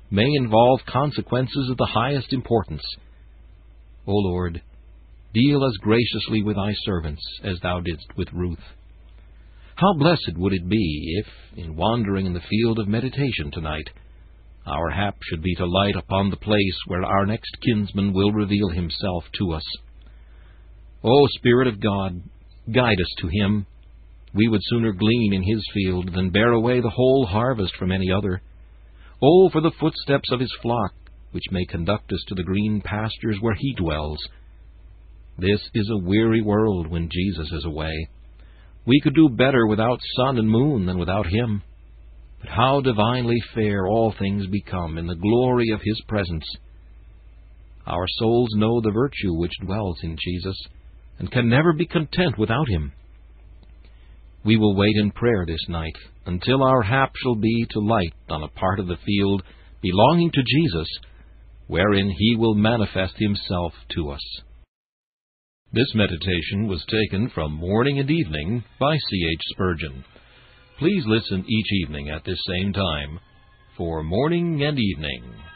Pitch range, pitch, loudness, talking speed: 85-115 Hz, 100 Hz, -22 LUFS, 155 wpm